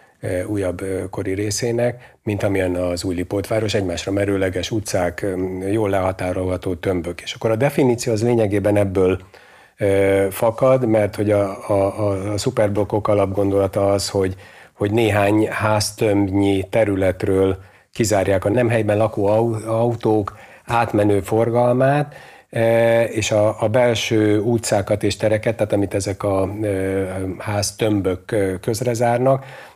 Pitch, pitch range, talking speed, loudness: 105 Hz, 95-110 Hz, 115 wpm, -19 LUFS